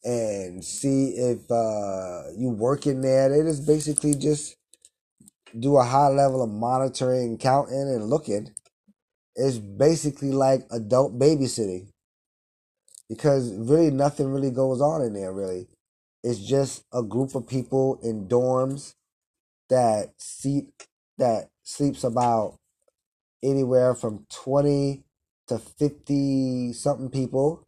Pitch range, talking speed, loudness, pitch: 120-140 Hz, 120 wpm, -24 LUFS, 130 Hz